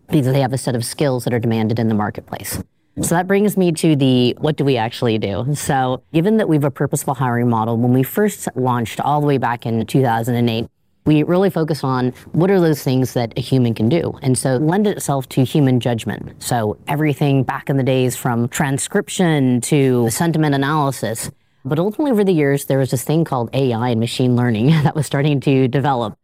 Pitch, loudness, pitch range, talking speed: 135 Hz, -17 LUFS, 120-155 Hz, 215 wpm